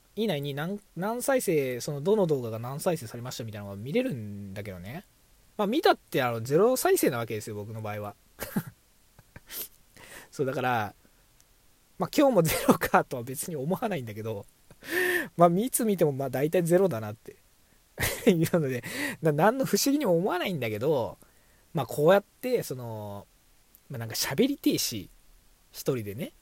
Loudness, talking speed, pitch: -28 LUFS, 320 characters per minute, 150 Hz